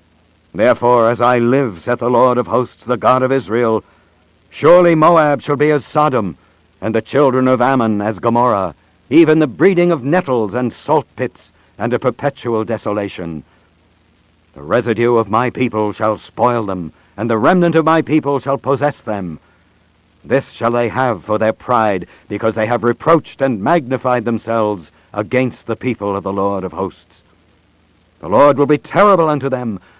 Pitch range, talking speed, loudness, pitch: 90-130 Hz, 170 wpm, -15 LUFS, 115 Hz